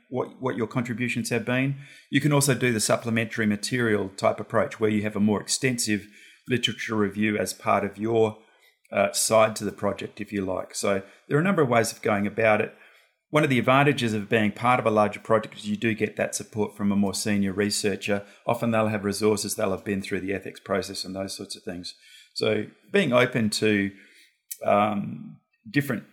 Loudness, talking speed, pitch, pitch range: -25 LUFS, 205 wpm, 110 Hz, 100-120 Hz